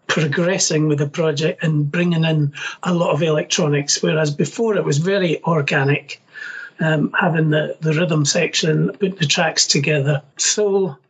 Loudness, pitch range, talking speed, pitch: -18 LUFS, 150-180 Hz, 150 wpm, 160 Hz